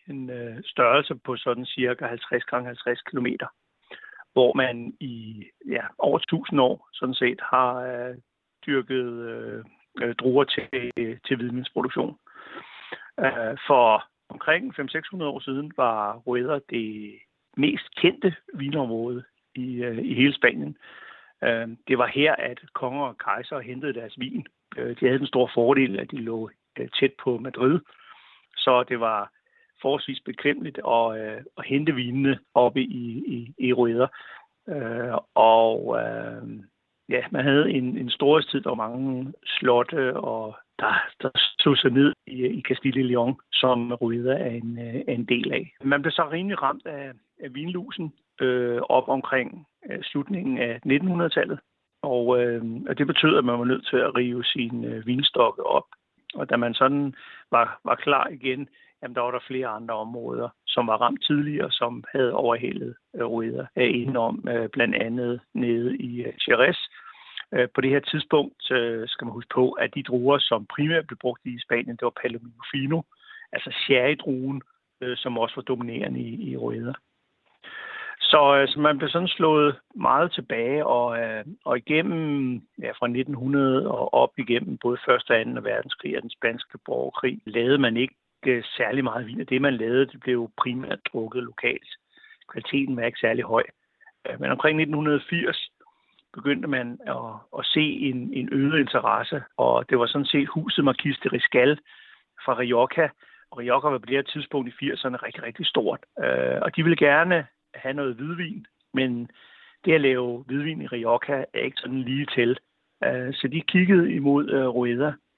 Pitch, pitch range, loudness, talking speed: 130 Hz, 120-145 Hz, -24 LUFS, 165 wpm